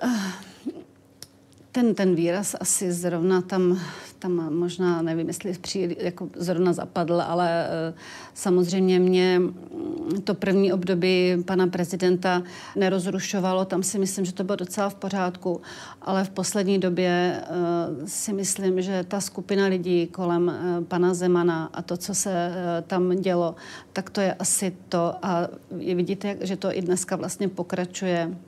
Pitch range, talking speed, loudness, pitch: 175-190 Hz, 135 wpm, -25 LUFS, 180 Hz